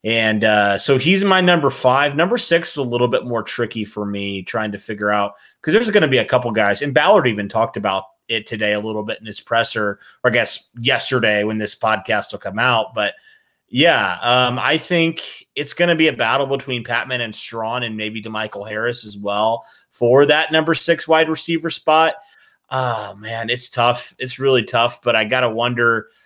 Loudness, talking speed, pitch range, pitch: -18 LUFS, 210 wpm, 110-145 Hz, 120 Hz